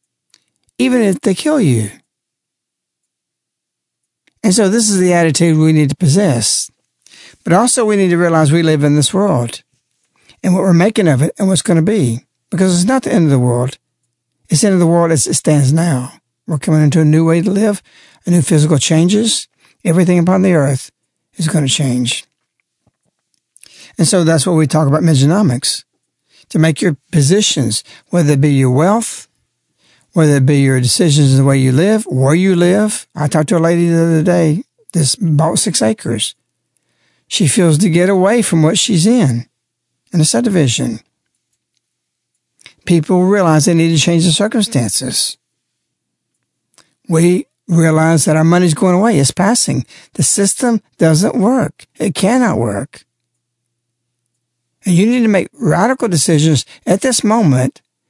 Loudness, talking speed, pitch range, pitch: -12 LUFS, 165 wpm, 145-190 Hz, 165 Hz